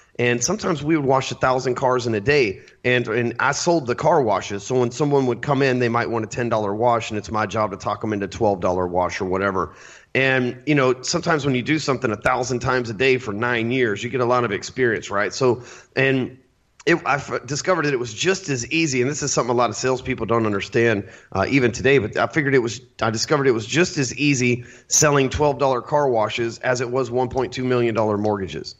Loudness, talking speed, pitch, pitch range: -21 LUFS, 250 wpm, 125 Hz, 115-135 Hz